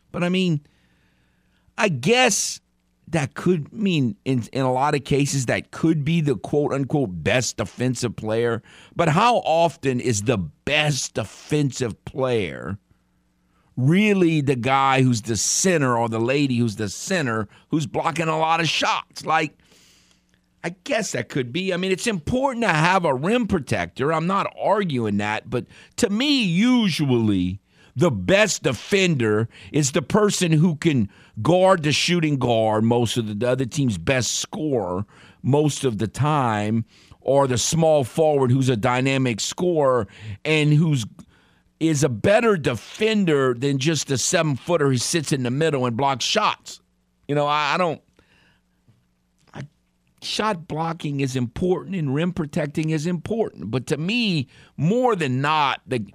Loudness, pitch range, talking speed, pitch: -21 LUFS, 120-165 Hz, 155 wpm, 140 Hz